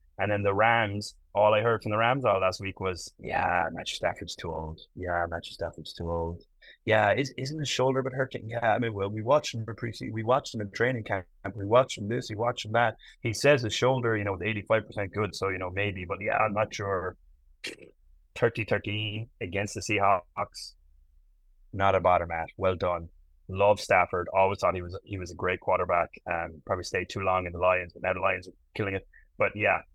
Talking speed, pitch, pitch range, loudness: 225 wpm, 100 Hz, 90-110 Hz, -28 LUFS